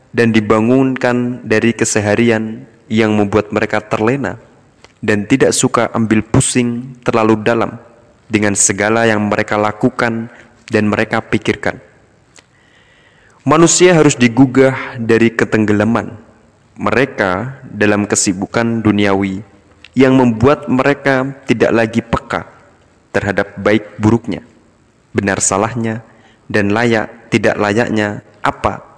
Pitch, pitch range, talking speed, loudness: 115 Hz, 105-125 Hz, 100 wpm, -14 LUFS